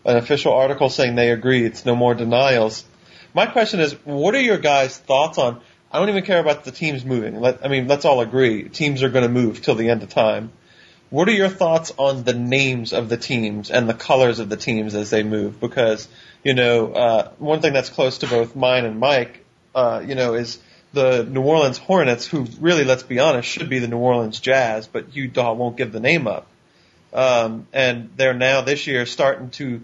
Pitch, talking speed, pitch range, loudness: 125 Hz, 220 wpm, 115-140 Hz, -19 LUFS